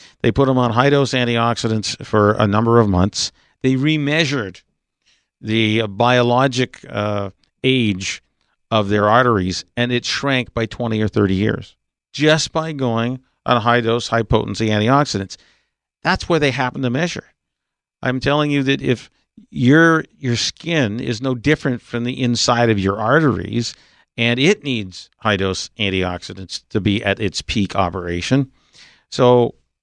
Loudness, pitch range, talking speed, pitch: -18 LUFS, 105-130 Hz, 150 wpm, 120 Hz